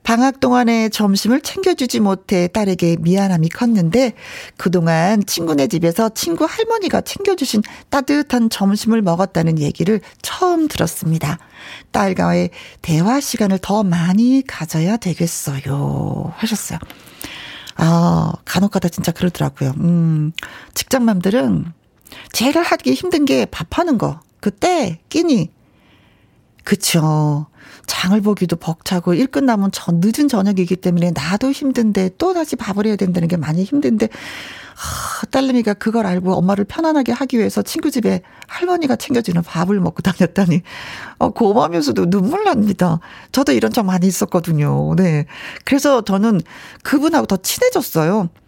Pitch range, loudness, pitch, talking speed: 170-250 Hz, -17 LUFS, 200 Hz, 305 characters per minute